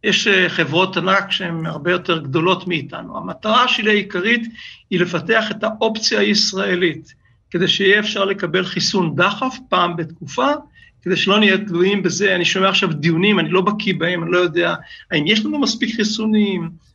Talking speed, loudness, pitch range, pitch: 160 wpm, -17 LUFS, 175-210 Hz, 190 Hz